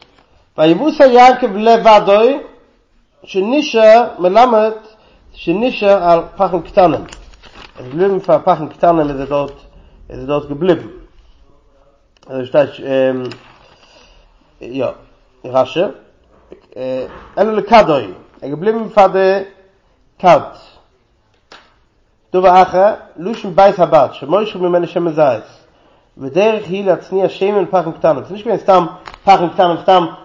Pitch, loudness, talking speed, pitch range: 185 Hz, -13 LUFS, 105 wpm, 160-205 Hz